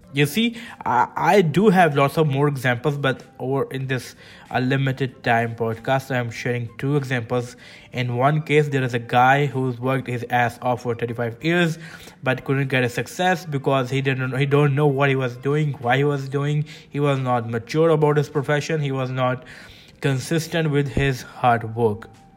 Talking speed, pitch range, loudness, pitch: 190 wpm, 125-150 Hz, -21 LUFS, 135 Hz